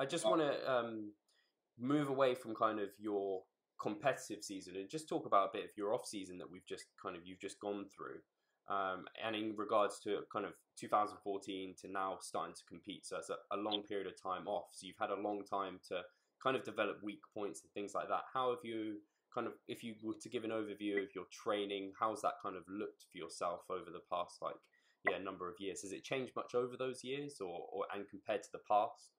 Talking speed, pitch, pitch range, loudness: 240 wpm, 105 Hz, 100-120 Hz, -41 LUFS